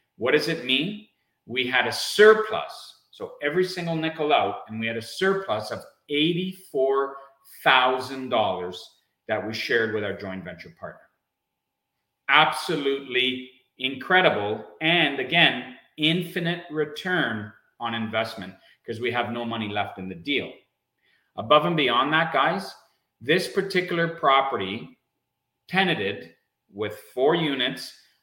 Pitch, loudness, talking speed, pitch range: 135 Hz, -24 LUFS, 120 wpm, 110-165 Hz